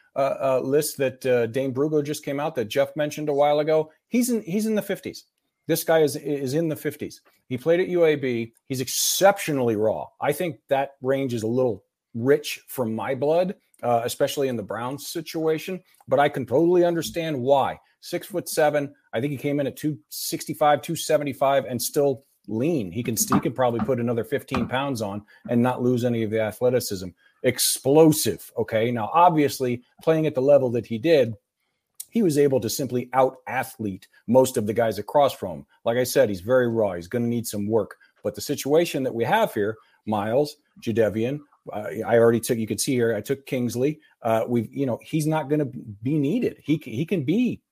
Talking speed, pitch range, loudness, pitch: 200 wpm, 120-155 Hz, -24 LUFS, 135 Hz